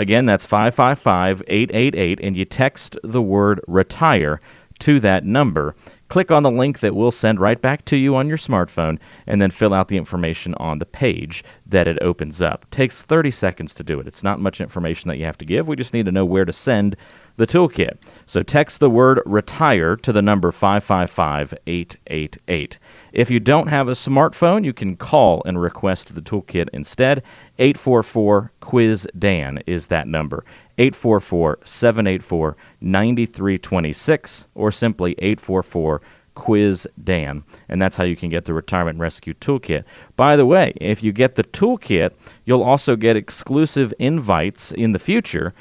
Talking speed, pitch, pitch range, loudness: 165 wpm, 100 Hz, 90-125 Hz, -18 LUFS